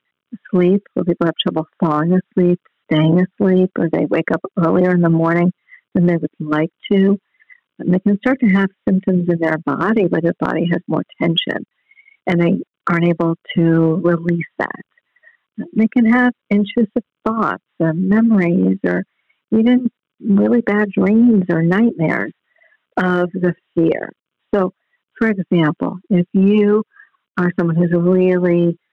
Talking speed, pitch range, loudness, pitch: 145 wpm, 170-210 Hz, -17 LUFS, 185 Hz